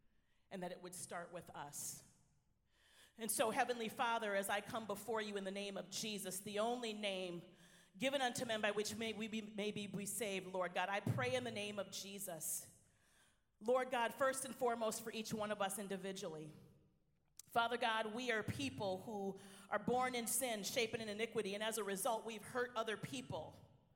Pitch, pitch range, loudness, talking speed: 205 Hz, 185-225 Hz, -42 LUFS, 190 wpm